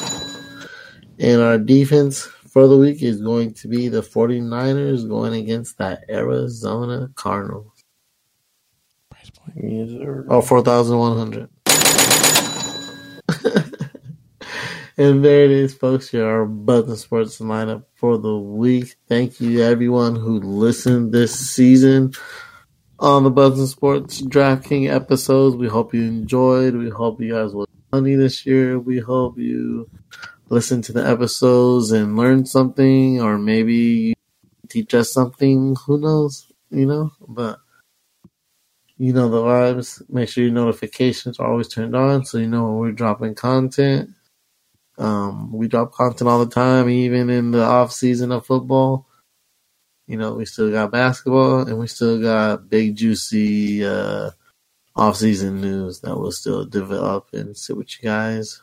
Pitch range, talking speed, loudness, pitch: 115-130 Hz, 140 wpm, -17 LUFS, 120 Hz